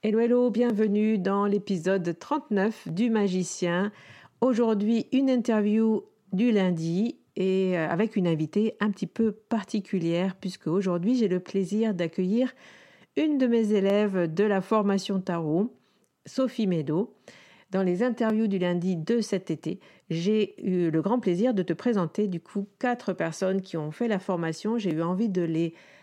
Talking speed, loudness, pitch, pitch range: 155 wpm, -27 LUFS, 200 Hz, 180-225 Hz